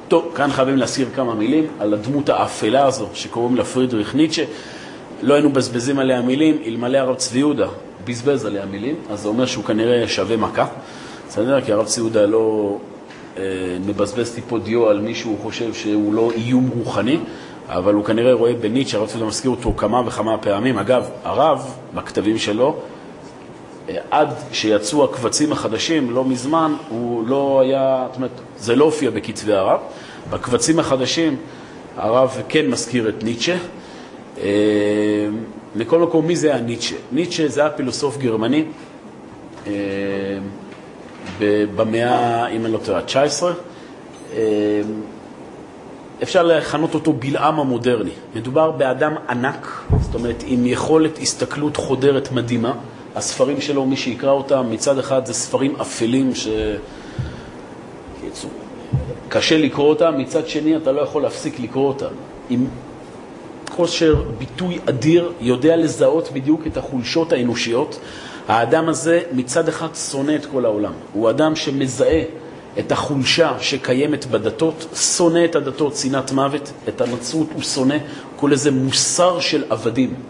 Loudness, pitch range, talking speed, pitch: -19 LUFS, 115-150 Hz, 135 wpm, 130 Hz